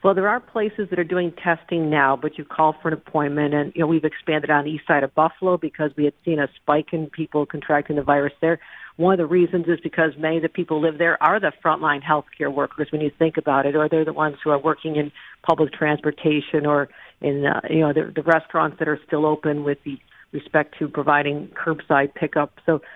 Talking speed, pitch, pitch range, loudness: 240 wpm, 155 Hz, 150-165 Hz, -21 LUFS